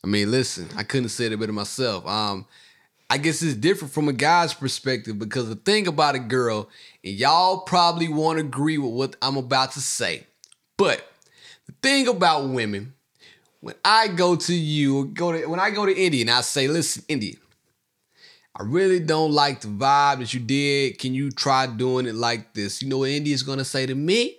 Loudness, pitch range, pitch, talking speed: -22 LUFS, 125-160 Hz, 135 Hz, 205 wpm